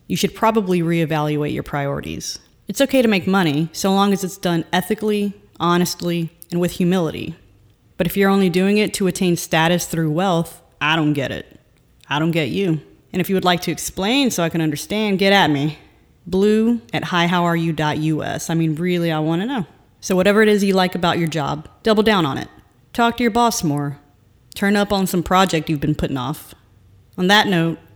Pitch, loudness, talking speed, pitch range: 175 Hz, -19 LUFS, 200 wpm, 155-195 Hz